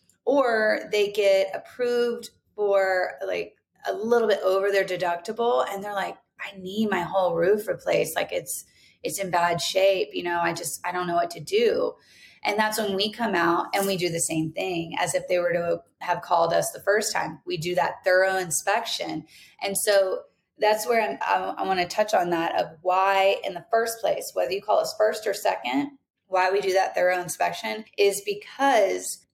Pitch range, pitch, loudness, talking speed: 175-220 Hz, 195 Hz, -25 LUFS, 200 wpm